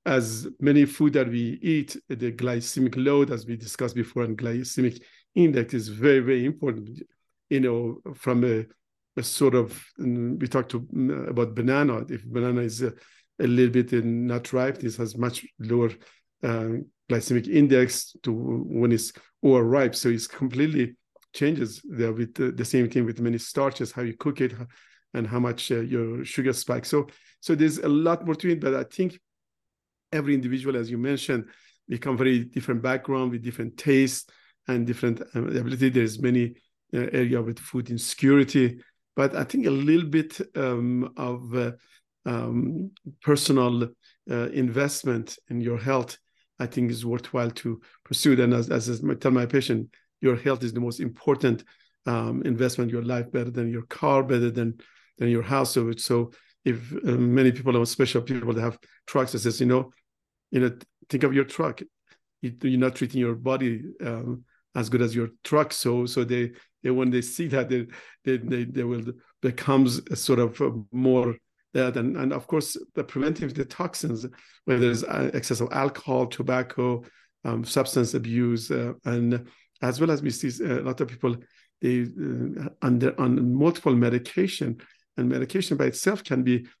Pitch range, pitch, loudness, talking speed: 120-135 Hz, 125 Hz, -25 LUFS, 170 wpm